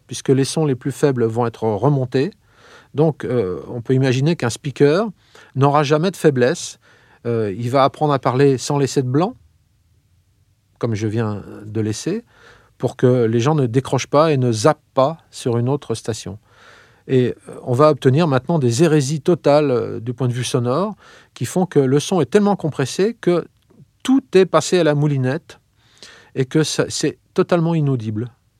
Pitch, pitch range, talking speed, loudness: 135 Hz, 120-155 Hz, 175 wpm, -18 LUFS